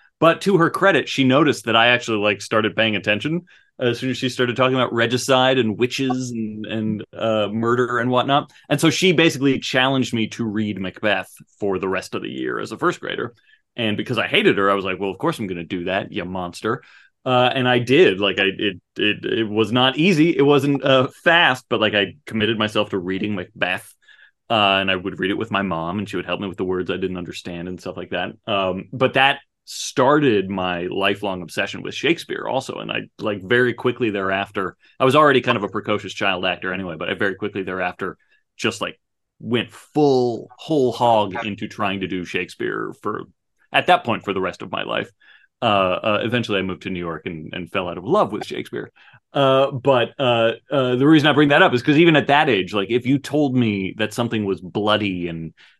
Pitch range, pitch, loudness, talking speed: 95-130 Hz, 110 Hz, -20 LUFS, 225 wpm